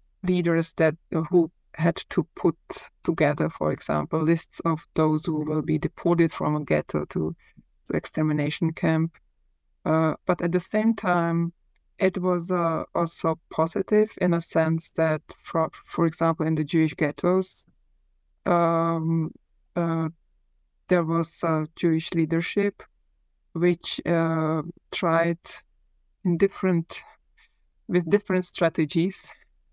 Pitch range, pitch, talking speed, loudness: 160-175 Hz, 165 Hz, 120 wpm, -25 LUFS